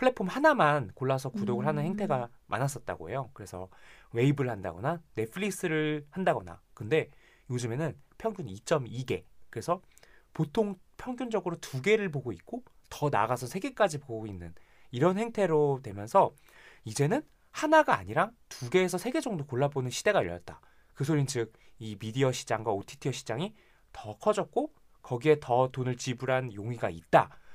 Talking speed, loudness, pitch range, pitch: 330 characters per minute, -30 LUFS, 120-185 Hz, 140 Hz